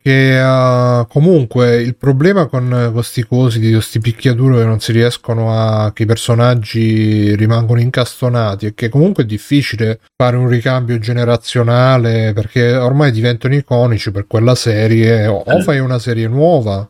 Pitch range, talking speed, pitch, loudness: 115-130 Hz, 150 wpm, 120 Hz, -12 LUFS